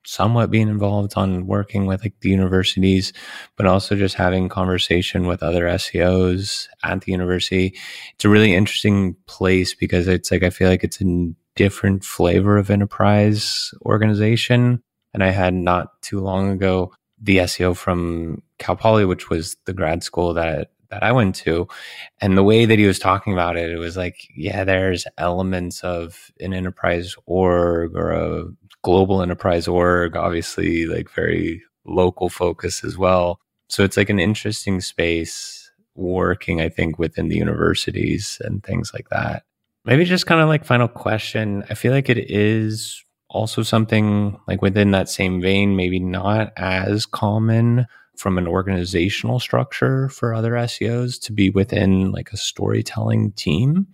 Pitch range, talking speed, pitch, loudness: 90-105 Hz, 160 wpm, 95 Hz, -19 LUFS